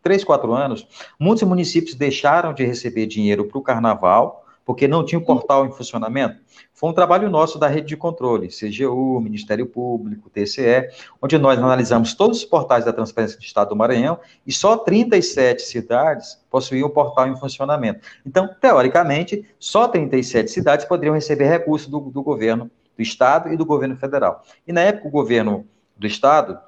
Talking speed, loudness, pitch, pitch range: 170 wpm, -18 LUFS, 140 Hz, 120-170 Hz